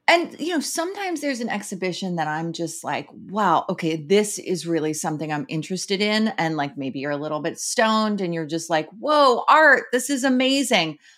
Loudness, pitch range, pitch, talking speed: -22 LUFS, 160-250 Hz, 190 Hz, 200 wpm